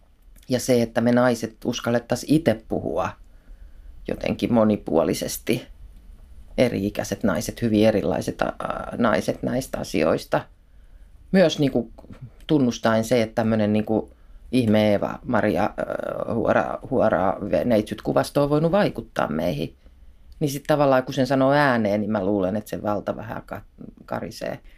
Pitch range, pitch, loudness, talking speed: 100-125 Hz, 110 Hz, -23 LUFS, 120 wpm